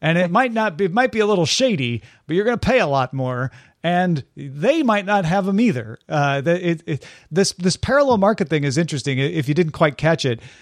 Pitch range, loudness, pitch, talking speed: 140-200 Hz, -19 LUFS, 170 Hz, 250 wpm